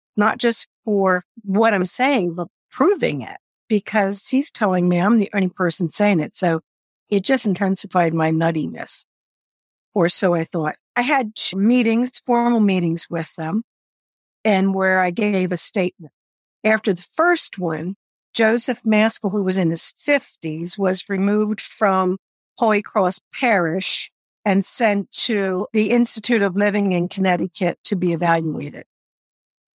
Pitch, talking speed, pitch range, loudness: 195 Hz, 145 wpm, 180-220 Hz, -19 LUFS